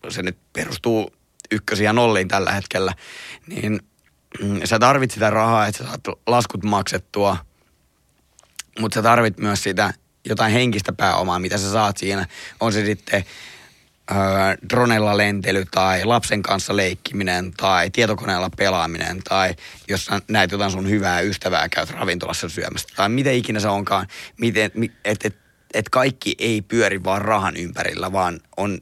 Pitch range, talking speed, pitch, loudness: 95-110 Hz, 140 wpm, 100 Hz, -20 LUFS